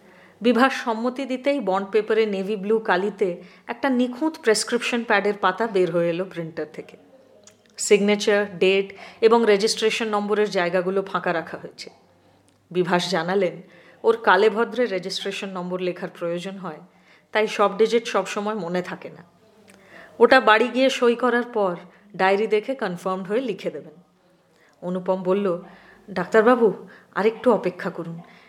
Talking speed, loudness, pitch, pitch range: 130 wpm, -22 LUFS, 200 Hz, 185-225 Hz